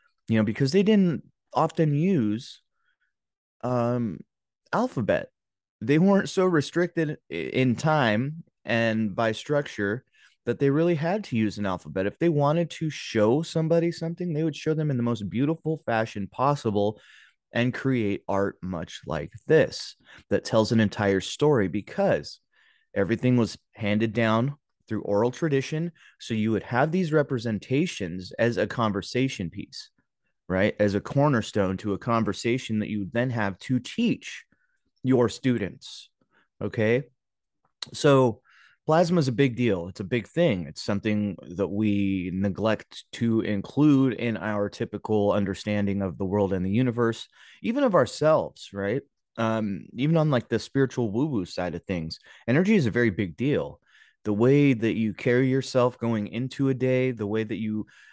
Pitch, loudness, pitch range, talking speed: 115 Hz, -26 LUFS, 105-145 Hz, 155 wpm